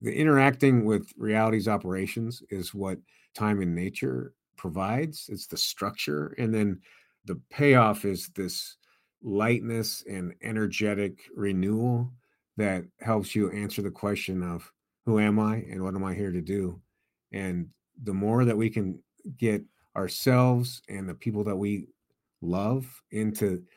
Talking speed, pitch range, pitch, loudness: 140 wpm, 95-115 Hz, 105 Hz, -28 LUFS